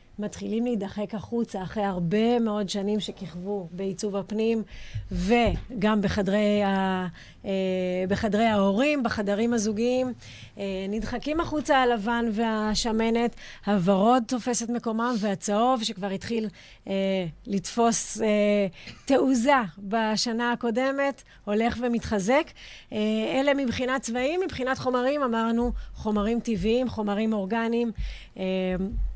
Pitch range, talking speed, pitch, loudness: 200-240 Hz, 85 wpm, 220 Hz, -26 LUFS